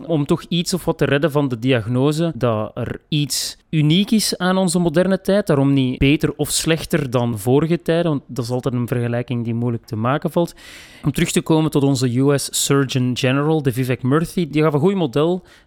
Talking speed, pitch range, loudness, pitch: 210 wpm, 130-170 Hz, -19 LUFS, 150 Hz